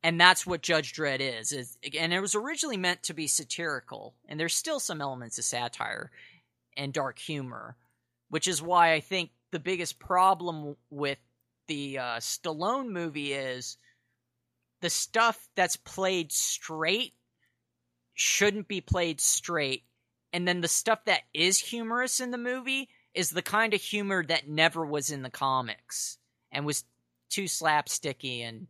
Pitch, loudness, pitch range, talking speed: 160 Hz, -29 LUFS, 130-185 Hz, 155 wpm